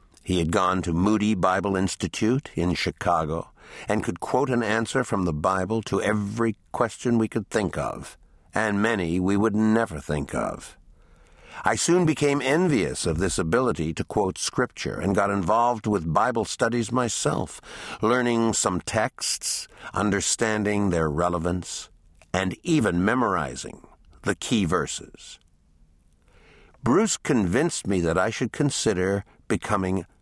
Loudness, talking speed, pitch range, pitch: -24 LUFS, 135 wpm, 85-110 Hz, 95 Hz